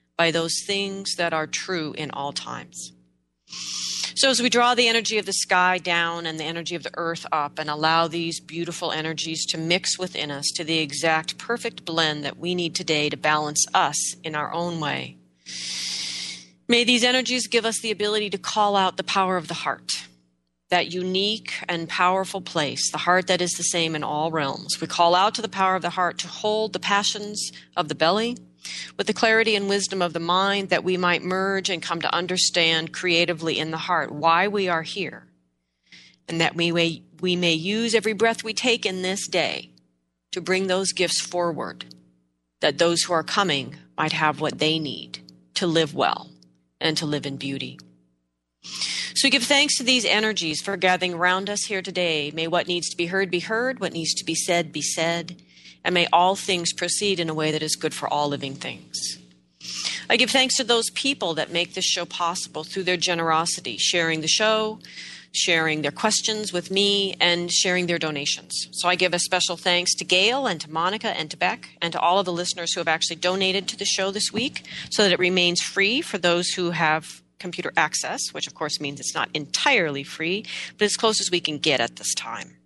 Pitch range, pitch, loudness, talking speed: 155-190 Hz, 175 Hz, -22 LUFS, 205 wpm